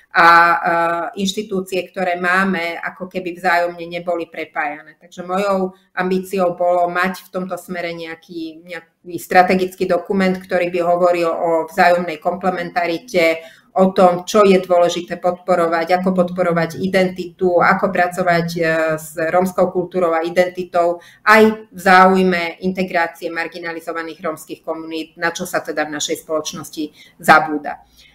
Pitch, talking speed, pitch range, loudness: 175 Hz, 125 wpm, 165-185 Hz, -17 LUFS